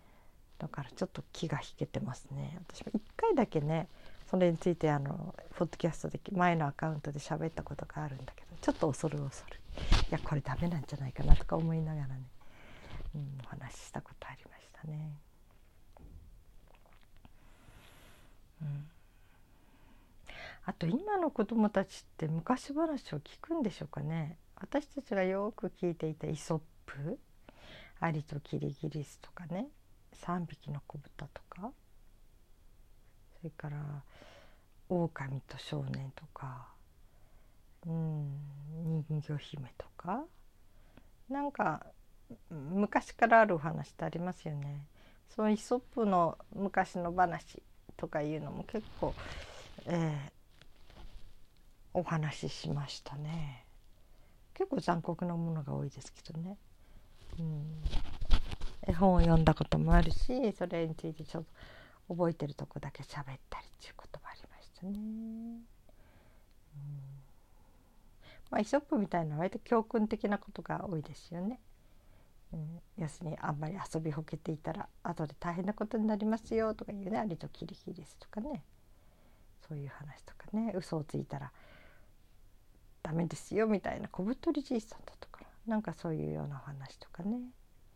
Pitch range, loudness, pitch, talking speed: 130-185 Hz, -36 LUFS, 155 Hz, 280 characters per minute